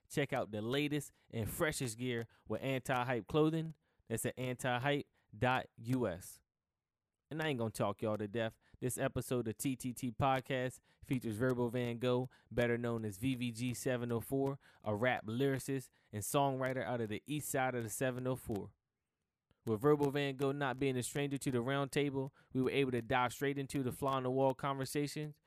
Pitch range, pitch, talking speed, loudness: 115-140 Hz, 125 Hz, 165 wpm, -38 LUFS